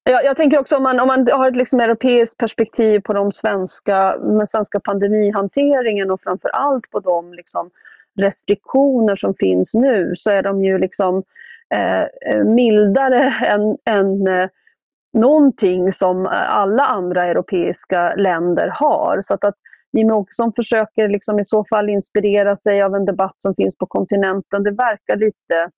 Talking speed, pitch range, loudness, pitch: 150 wpm, 195-235 Hz, -16 LUFS, 205 Hz